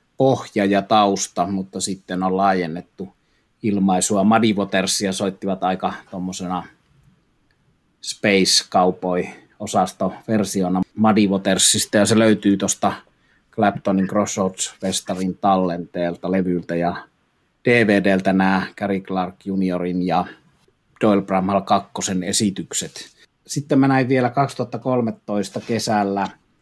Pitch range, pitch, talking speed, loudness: 95-105 Hz, 95 Hz, 95 wpm, -20 LUFS